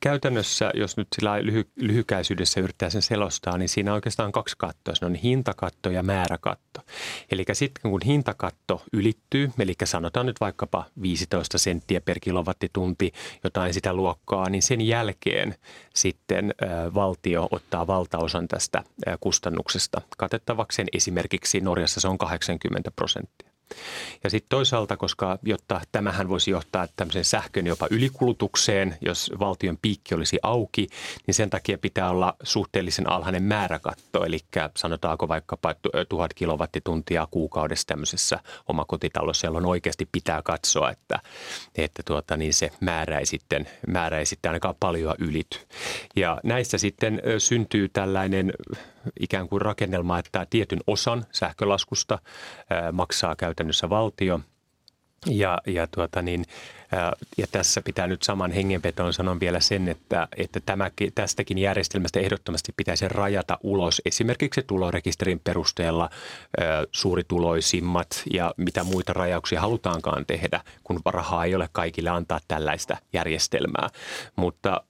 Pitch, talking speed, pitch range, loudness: 95 Hz, 130 wpm, 90-105 Hz, -26 LUFS